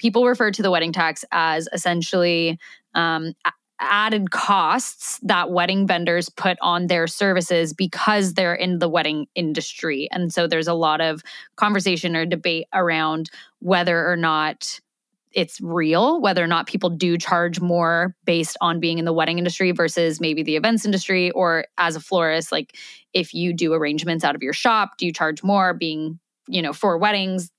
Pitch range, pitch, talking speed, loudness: 165-185 Hz, 175 Hz, 175 wpm, -20 LUFS